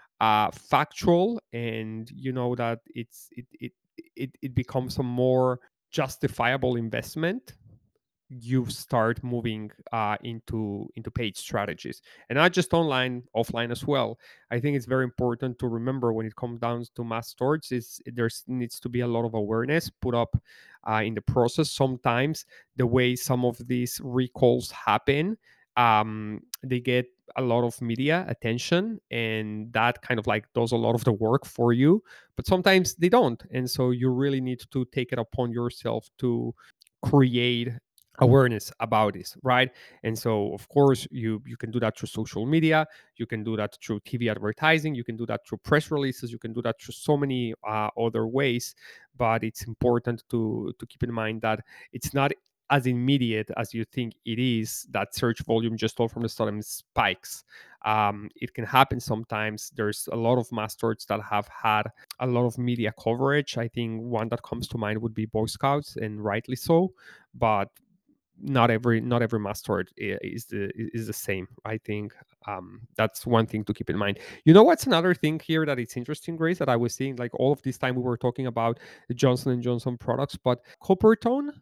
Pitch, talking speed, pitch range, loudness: 120 Hz, 190 wpm, 110-130 Hz, -26 LUFS